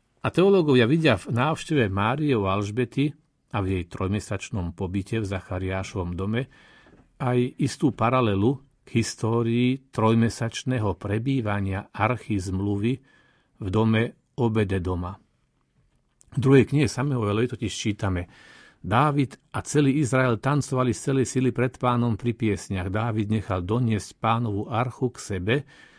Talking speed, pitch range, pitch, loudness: 125 wpm, 100-130 Hz, 115 Hz, -25 LUFS